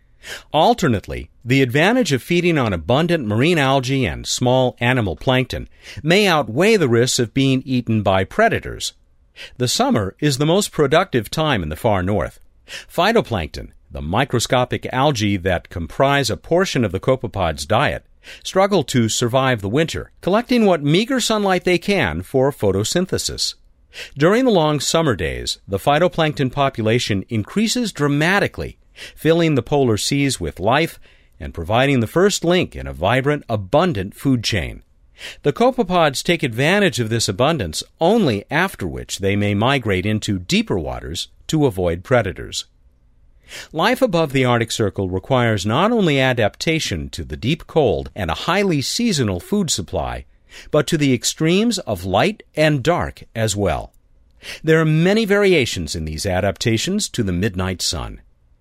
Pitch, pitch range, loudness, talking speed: 130 Hz, 100-165 Hz, -18 LUFS, 145 wpm